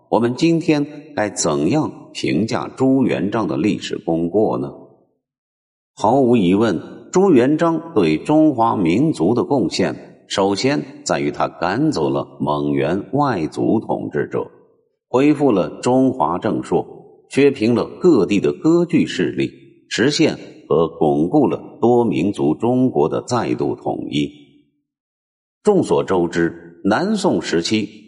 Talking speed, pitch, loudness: 190 characters per minute, 115 Hz, -18 LUFS